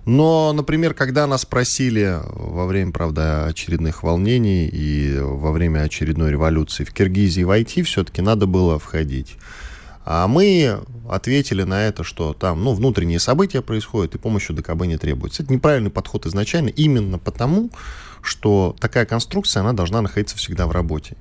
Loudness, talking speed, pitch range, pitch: -19 LUFS, 150 wpm, 80-120 Hz, 100 Hz